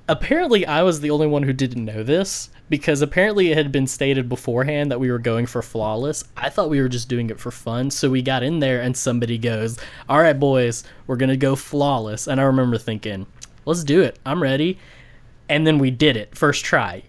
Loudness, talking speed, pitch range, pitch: -20 LUFS, 220 wpm, 120-145 Hz, 130 Hz